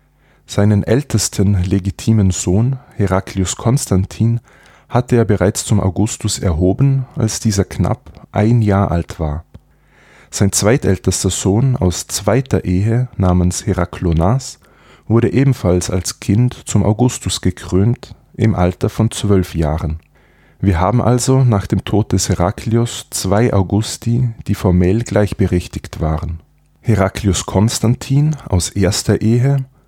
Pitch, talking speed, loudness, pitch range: 105 Hz, 115 wpm, -16 LUFS, 95-115 Hz